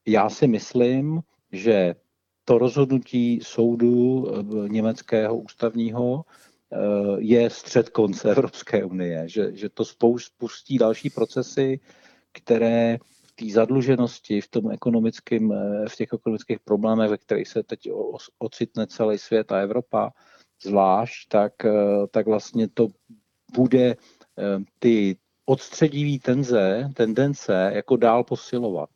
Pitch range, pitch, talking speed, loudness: 105-125 Hz, 115 Hz, 110 wpm, -23 LUFS